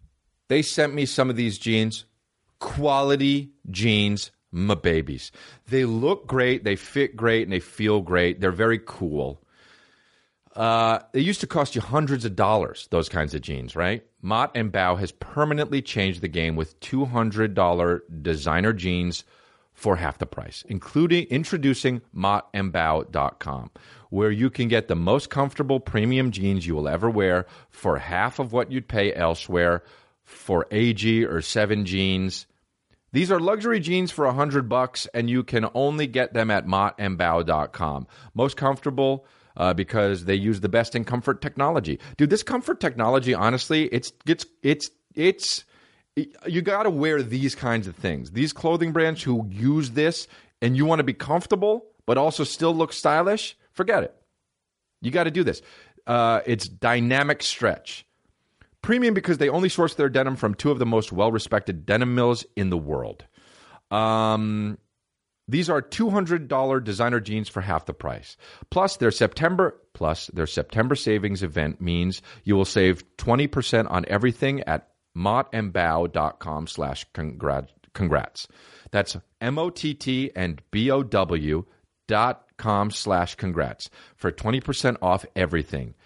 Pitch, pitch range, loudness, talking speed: 115 Hz, 95-140 Hz, -24 LUFS, 155 wpm